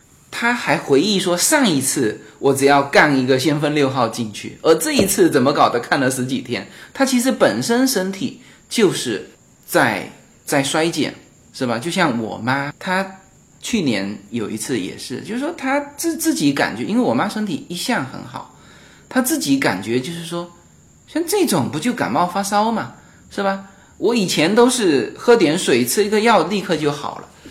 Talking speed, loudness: 255 characters per minute, -18 LUFS